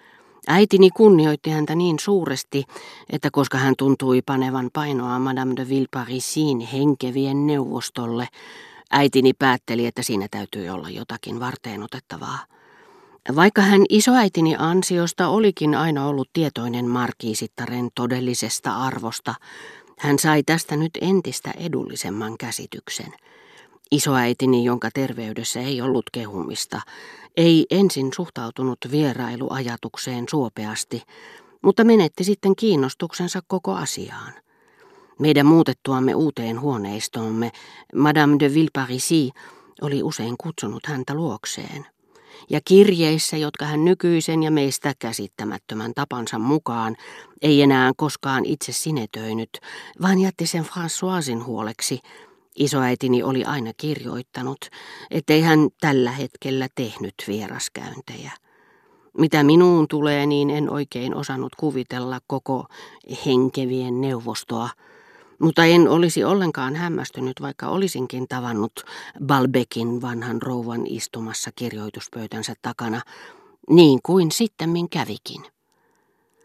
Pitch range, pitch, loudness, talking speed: 125-160 Hz, 135 Hz, -21 LUFS, 105 wpm